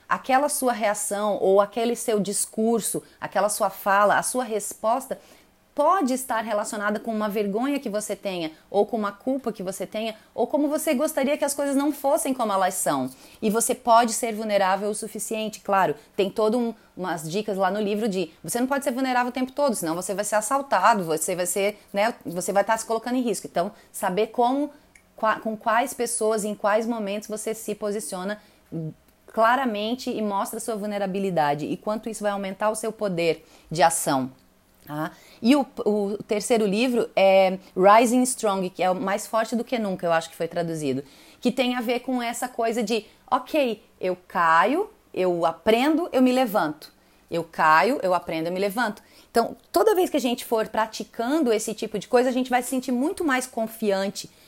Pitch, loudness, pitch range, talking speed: 215 Hz, -24 LUFS, 195-245 Hz, 190 wpm